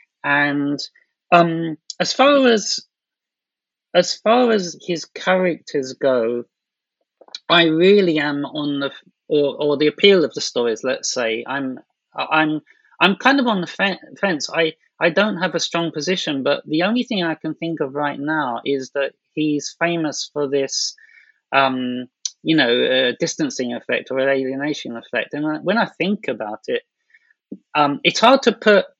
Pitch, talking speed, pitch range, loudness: 165 Hz, 160 wpm, 145-200 Hz, -19 LUFS